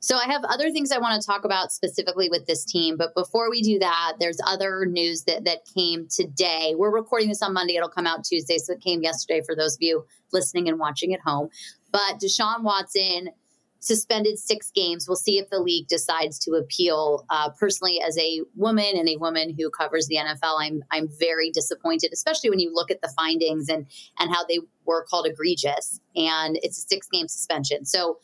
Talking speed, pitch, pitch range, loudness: 210 wpm, 170 Hz, 160-200 Hz, -24 LUFS